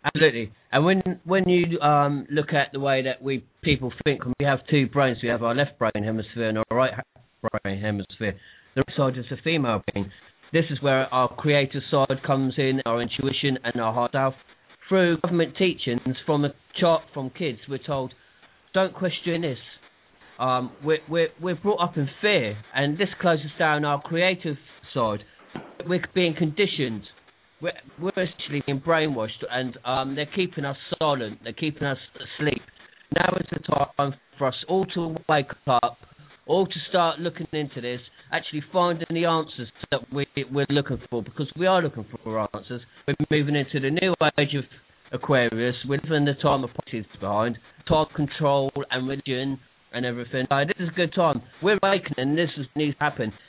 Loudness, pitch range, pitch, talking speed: -25 LUFS, 125-160 Hz, 140 Hz, 180 wpm